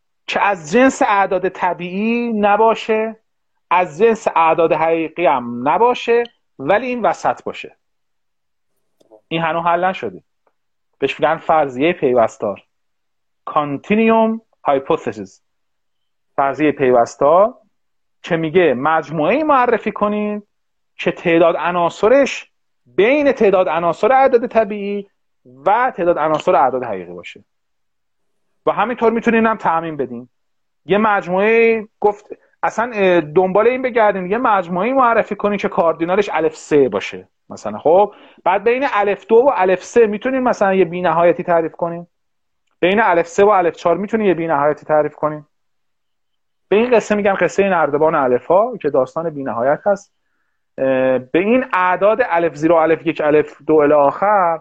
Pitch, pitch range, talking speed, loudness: 185 Hz, 160-220 Hz, 130 wpm, -16 LUFS